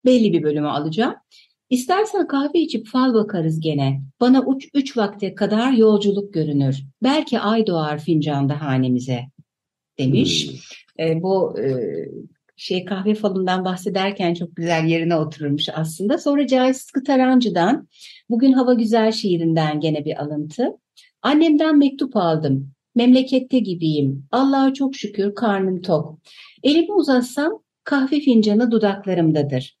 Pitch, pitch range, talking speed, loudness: 200 Hz, 155-260 Hz, 120 wpm, -19 LUFS